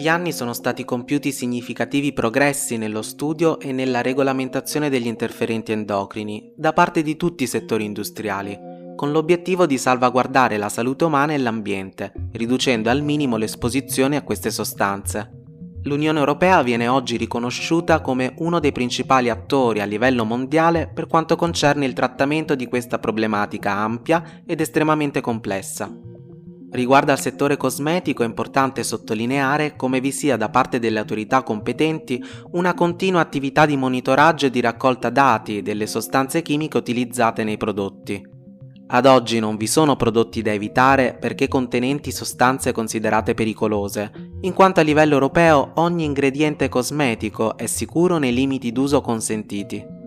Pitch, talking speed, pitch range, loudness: 130 Hz, 145 wpm, 110-145 Hz, -20 LUFS